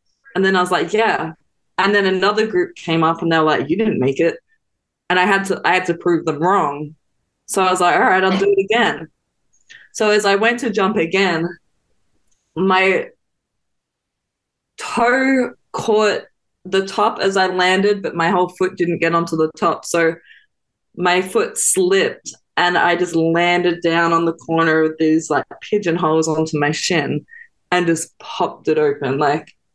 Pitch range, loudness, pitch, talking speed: 165-210 Hz, -17 LUFS, 180 Hz, 180 wpm